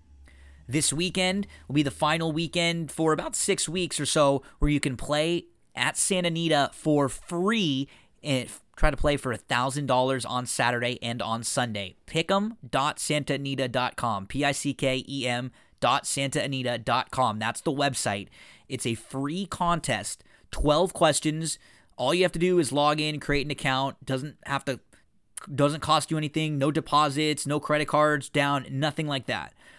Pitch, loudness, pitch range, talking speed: 145 Hz, -26 LUFS, 130-155 Hz, 150 wpm